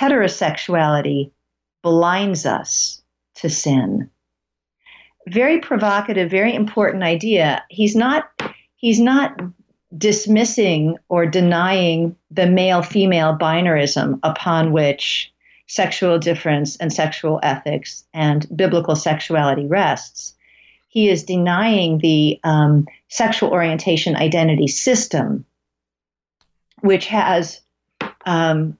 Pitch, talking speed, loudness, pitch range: 170 Hz, 90 wpm, -17 LUFS, 155-195 Hz